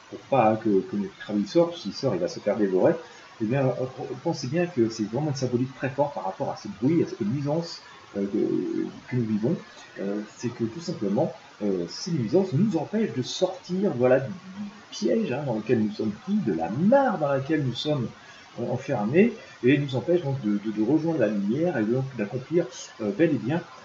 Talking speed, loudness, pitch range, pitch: 220 wpm, -26 LUFS, 115-175 Hz, 140 Hz